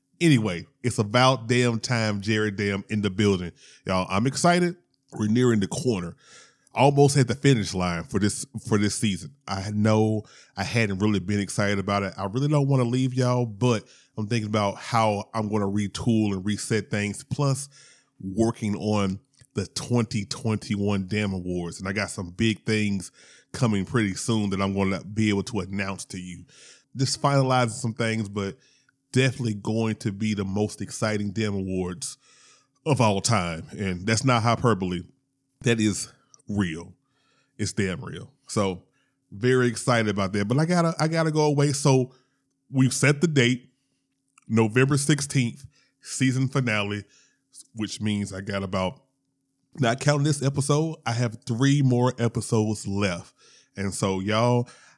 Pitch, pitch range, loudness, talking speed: 110 Hz, 100-130 Hz, -25 LUFS, 160 wpm